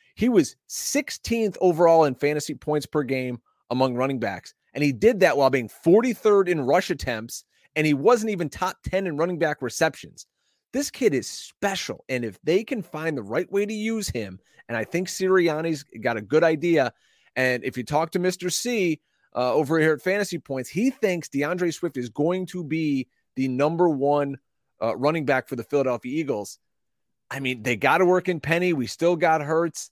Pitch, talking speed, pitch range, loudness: 160 Hz, 195 wpm, 135-185 Hz, -24 LUFS